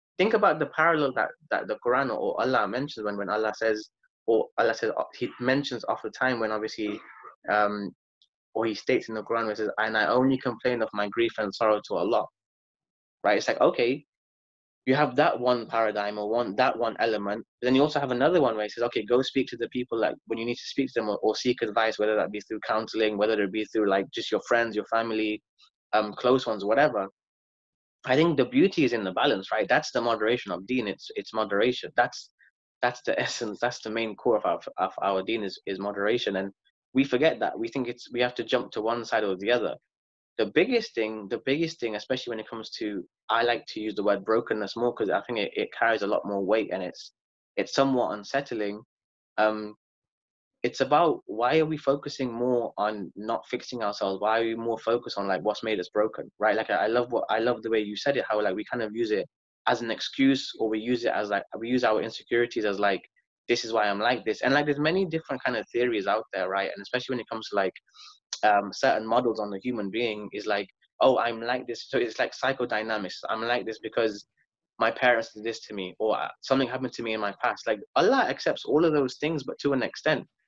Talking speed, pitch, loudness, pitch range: 240 wpm, 115 Hz, -27 LUFS, 105-125 Hz